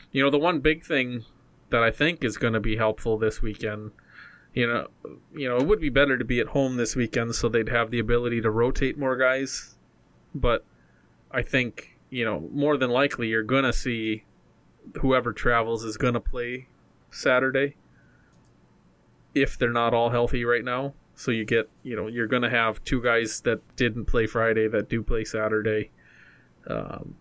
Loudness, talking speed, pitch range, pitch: -25 LUFS, 185 wpm, 110-130 Hz, 120 Hz